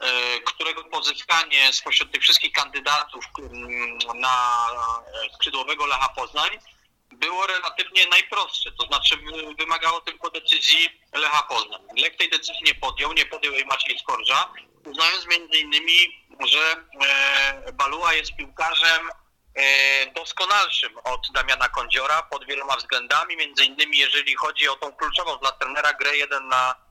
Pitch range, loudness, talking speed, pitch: 135-165 Hz, -20 LUFS, 125 wpm, 150 Hz